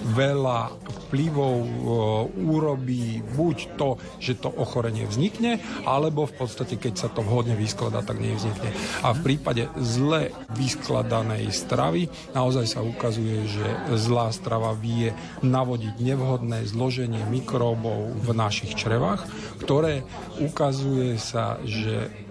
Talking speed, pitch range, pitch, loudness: 115 wpm, 110-130 Hz, 120 Hz, -26 LUFS